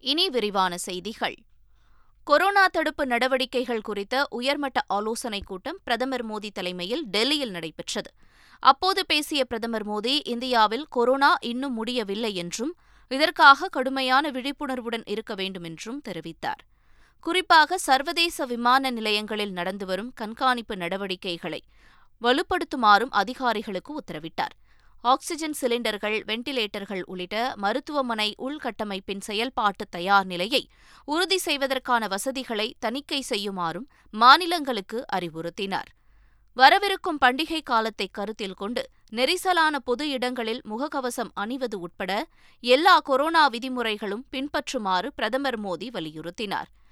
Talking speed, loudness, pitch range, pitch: 95 wpm, -24 LUFS, 205-275 Hz, 240 Hz